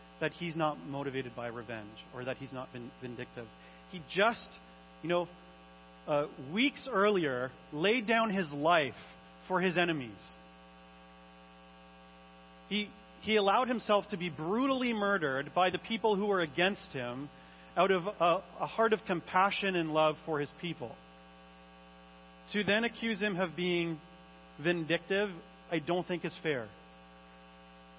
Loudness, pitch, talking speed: -32 LUFS, 145 Hz, 140 wpm